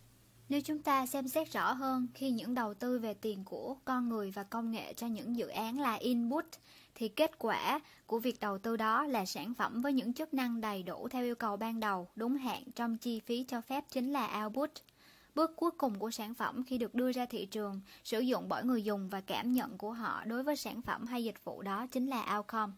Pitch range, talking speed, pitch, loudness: 215-260 Hz, 235 wpm, 235 Hz, -37 LUFS